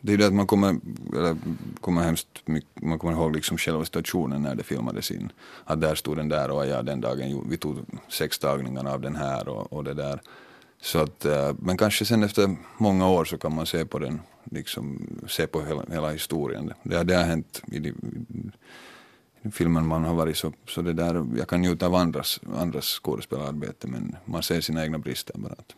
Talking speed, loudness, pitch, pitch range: 210 wpm, -27 LUFS, 80 Hz, 75-90 Hz